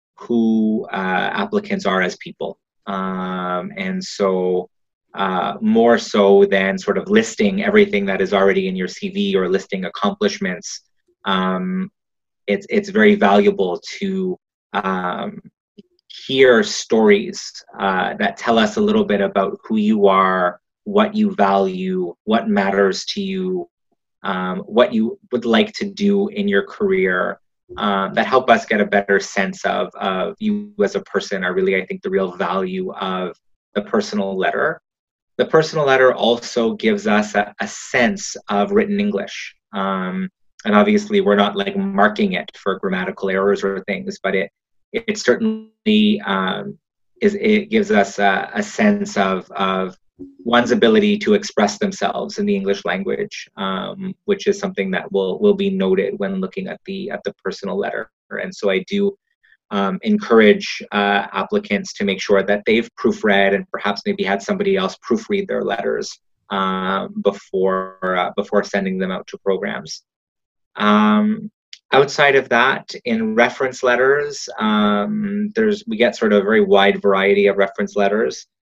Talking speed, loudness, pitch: 155 wpm, -18 LUFS, 130 Hz